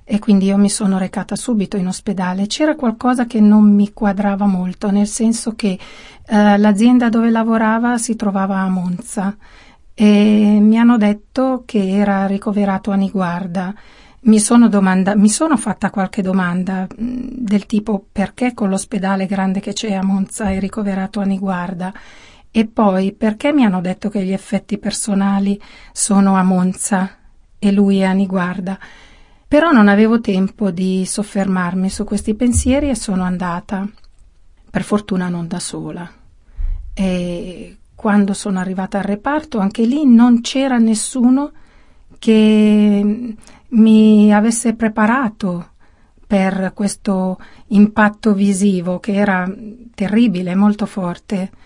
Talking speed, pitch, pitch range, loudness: 135 wpm, 205 Hz, 190-220 Hz, -15 LUFS